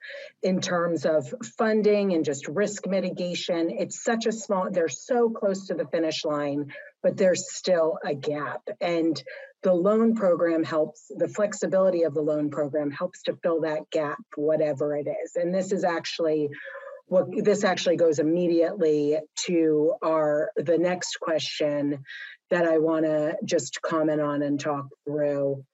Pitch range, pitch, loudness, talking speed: 155-190 Hz, 165 Hz, -26 LUFS, 155 wpm